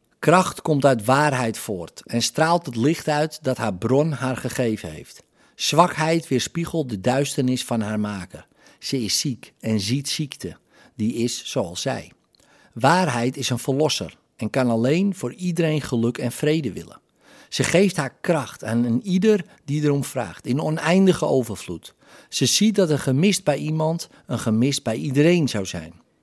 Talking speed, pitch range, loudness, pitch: 165 wpm, 120-155 Hz, -22 LUFS, 135 Hz